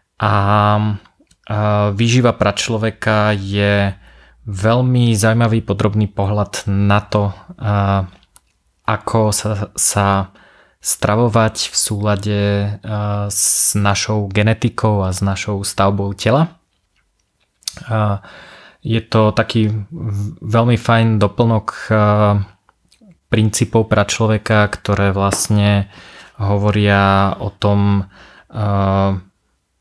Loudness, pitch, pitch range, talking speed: -16 LUFS, 105 Hz, 100-110 Hz, 75 wpm